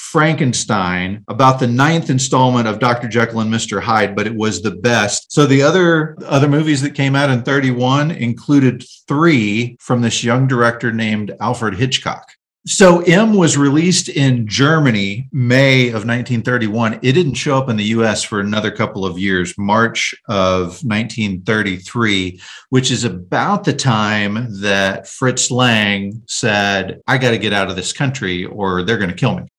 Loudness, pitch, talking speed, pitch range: -15 LUFS, 120 Hz, 165 wpm, 105-135 Hz